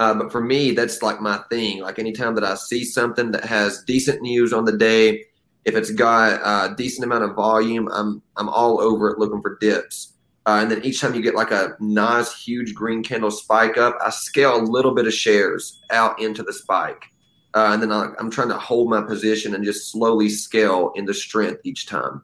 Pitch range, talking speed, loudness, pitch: 105-120 Hz, 220 wpm, -20 LUFS, 110 Hz